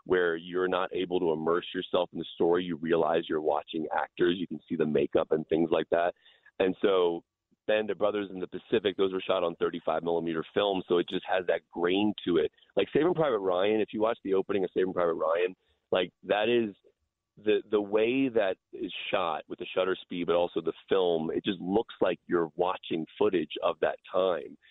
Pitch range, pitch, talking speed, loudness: 85-135 Hz, 95 Hz, 215 wpm, -29 LUFS